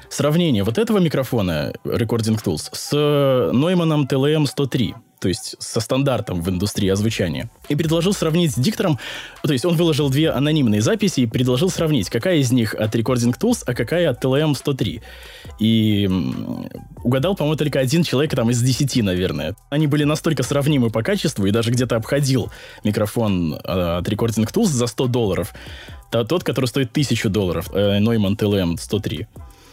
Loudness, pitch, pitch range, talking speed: -19 LUFS, 125 Hz, 110-150 Hz, 155 wpm